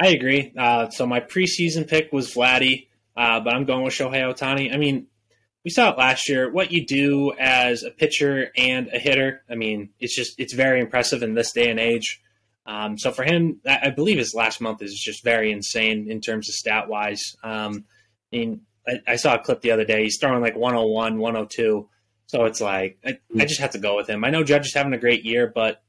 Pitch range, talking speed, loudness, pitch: 110-135 Hz, 230 wpm, -21 LUFS, 120 Hz